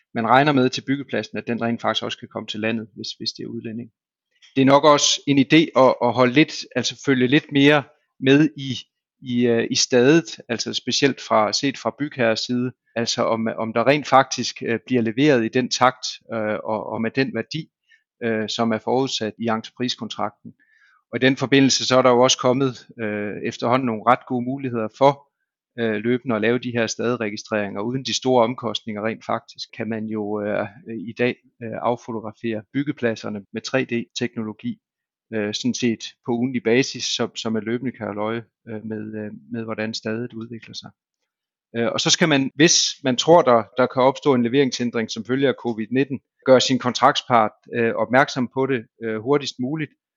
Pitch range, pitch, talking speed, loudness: 110-130 Hz, 120 Hz, 180 wpm, -21 LUFS